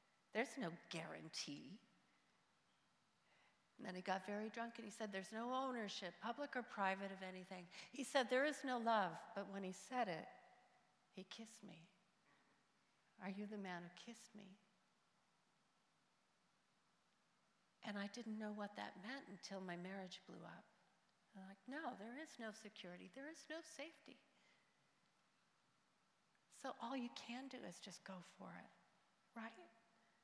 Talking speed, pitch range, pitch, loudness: 150 wpm, 190-240 Hz, 210 Hz, -49 LUFS